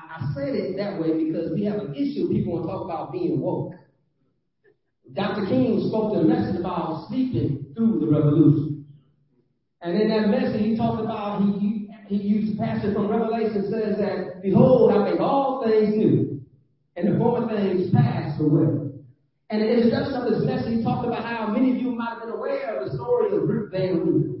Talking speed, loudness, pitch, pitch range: 200 wpm, -23 LUFS, 205 Hz, 155-225 Hz